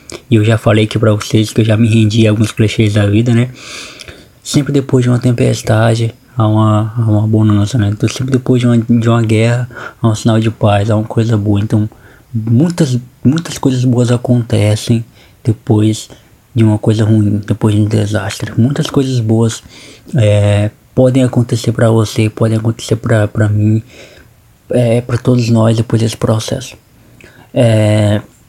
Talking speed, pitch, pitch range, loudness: 170 wpm, 115 Hz, 110-120 Hz, -12 LUFS